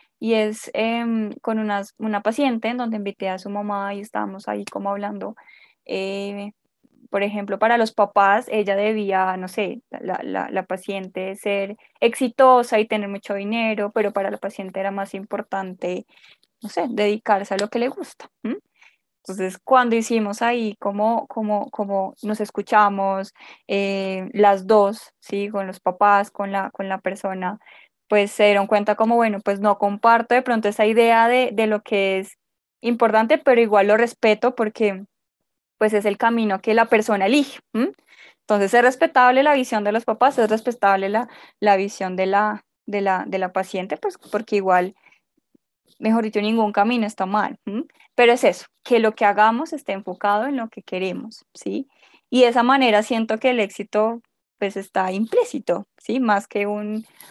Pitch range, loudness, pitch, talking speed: 200-230 Hz, -21 LUFS, 210 Hz, 175 wpm